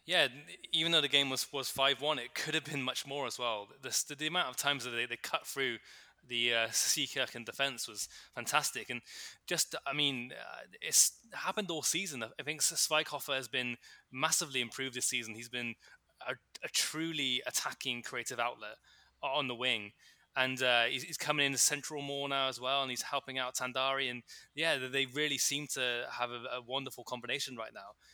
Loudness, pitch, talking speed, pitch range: -33 LUFS, 135 Hz, 200 wpm, 125-145 Hz